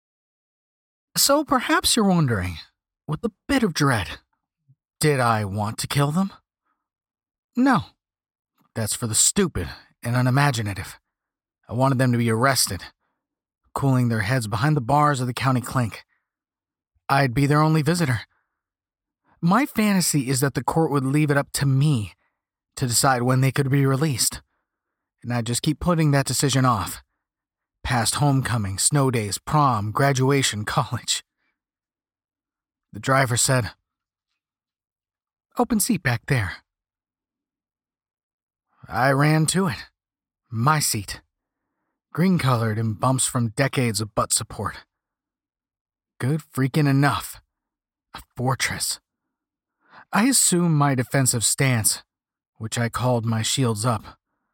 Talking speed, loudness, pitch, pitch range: 125 wpm, -21 LUFS, 135 Hz, 115-150 Hz